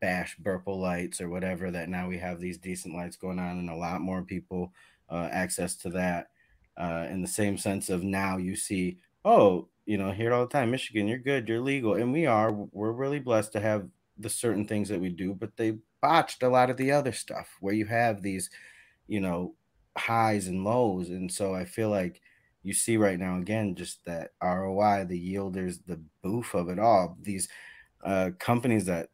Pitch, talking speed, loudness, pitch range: 95 Hz, 205 wpm, -29 LUFS, 90-110 Hz